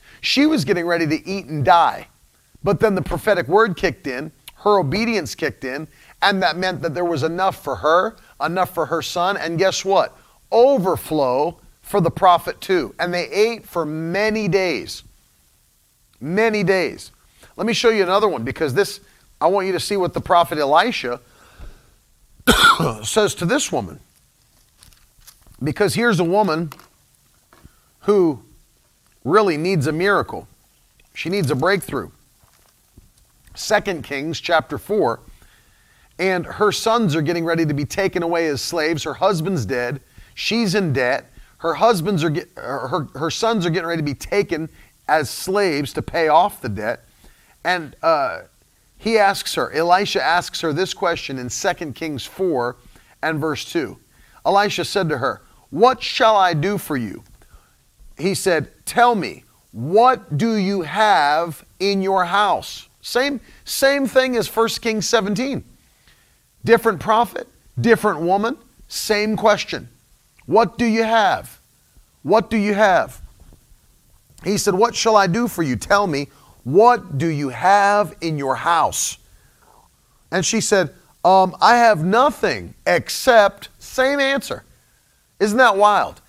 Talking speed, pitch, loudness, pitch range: 150 wpm, 190 Hz, -19 LUFS, 160-215 Hz